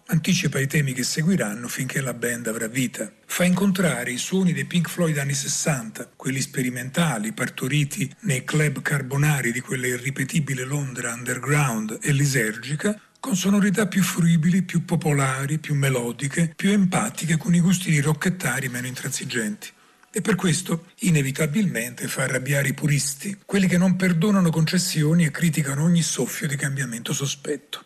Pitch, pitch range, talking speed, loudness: 150 Hz, 135-175 Hz, 150 wpm, -23 LUFS